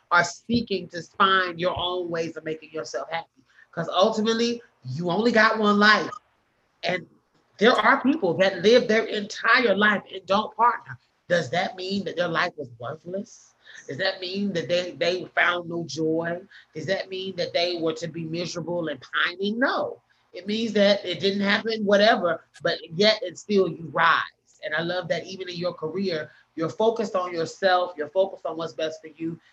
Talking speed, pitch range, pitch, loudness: 185 wpm, 165-205 Hz, 180 Hz, -24 LUFS